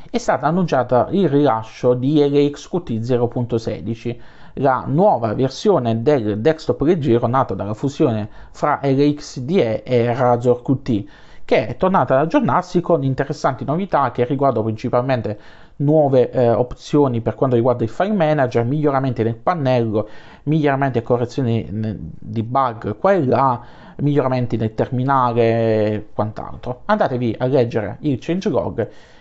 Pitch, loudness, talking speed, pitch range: 125 Hz, -18 LUFS, 130 wpm, 115-145 Hz